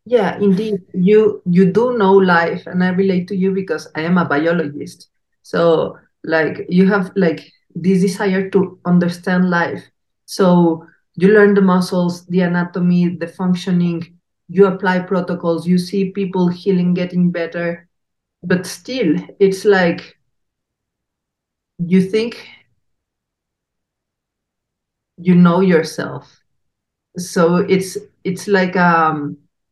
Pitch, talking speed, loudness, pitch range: 180 Hz, 120 wpm, -16 LUFS, 170-195 Hz